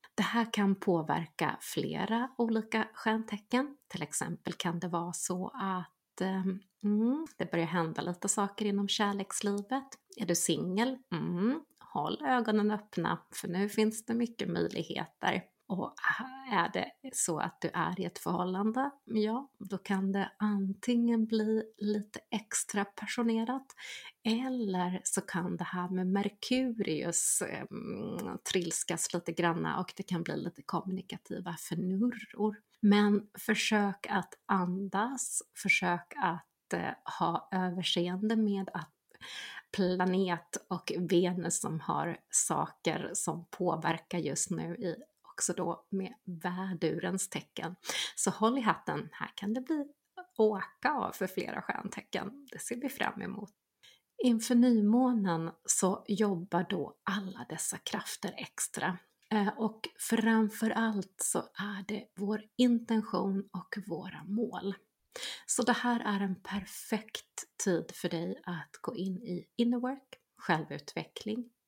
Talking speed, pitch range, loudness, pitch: 125 wpm, 185-225 Hz, -33 LUFS, 205 Hz